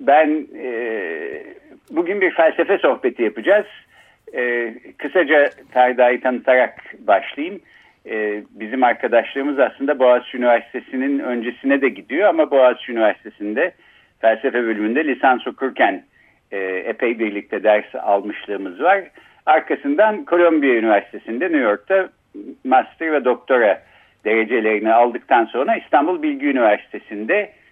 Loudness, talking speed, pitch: -18 LUFS, 105 wpm, 135 Hz